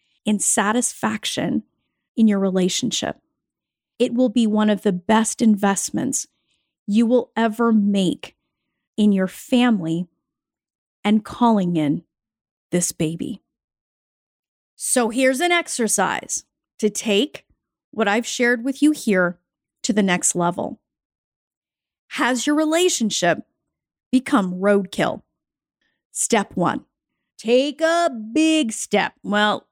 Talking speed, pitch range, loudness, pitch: 105 wpm, 195-250 Hz, -20 LUFS, 220 Hz